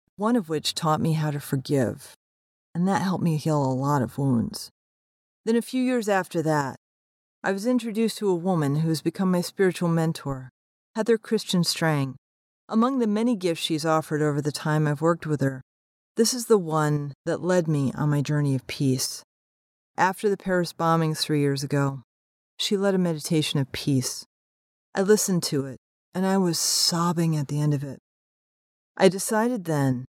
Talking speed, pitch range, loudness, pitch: 185 wpm, 135-190 Hz, -25 LUFS, 155 Hz